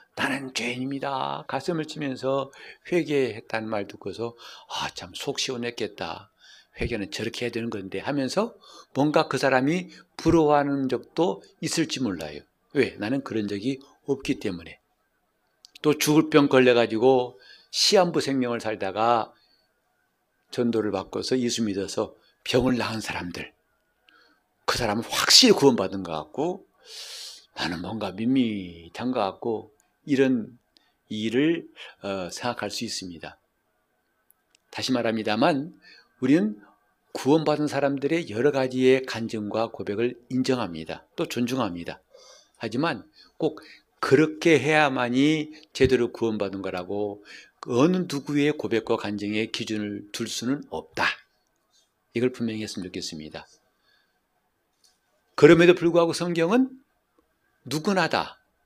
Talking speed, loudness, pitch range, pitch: 265 characters per minute, -25 LUFS, 110-140 Hz, 125 Hz